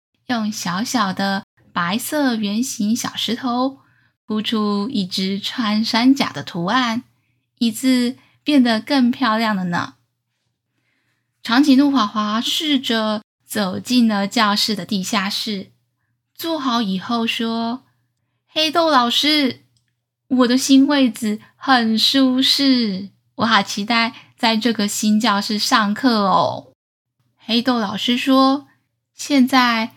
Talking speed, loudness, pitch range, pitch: 165 characters per minute, -18 LUFS, 195-255 Hz, 225 Hz